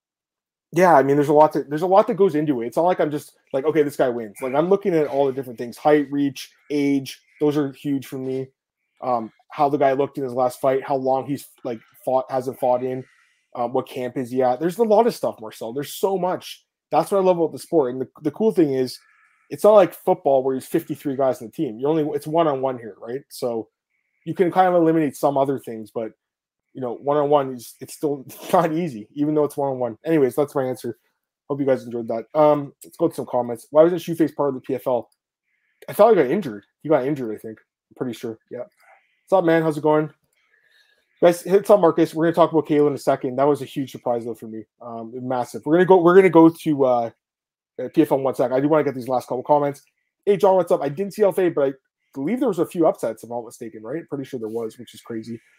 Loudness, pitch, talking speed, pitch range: -21 LUFS, 140 Hz, 260 wpm, 125-160 Hz